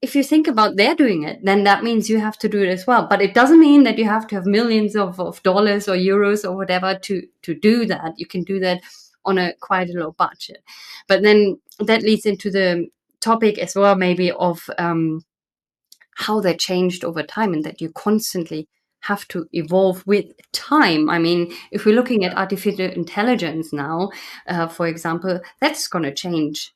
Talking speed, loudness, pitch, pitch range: 200 wpm, -18 LUFS, 190 Hz, 175-215 Hz